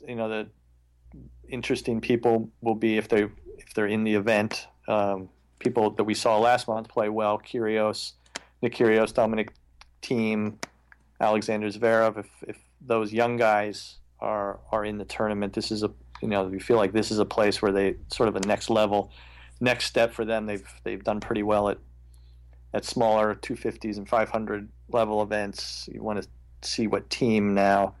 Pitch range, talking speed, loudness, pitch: 100-110 Hz, 180 wpm, -26 LUFS, 105 Hz